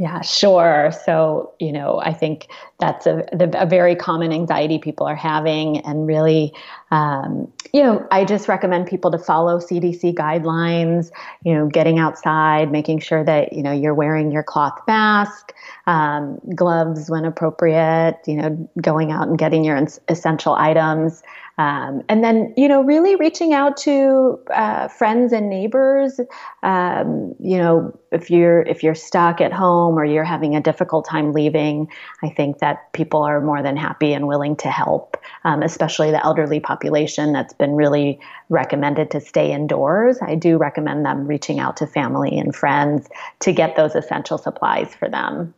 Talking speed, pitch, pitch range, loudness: 170 wpm, 160 Hz, 155-175 Hz, -18 LUFS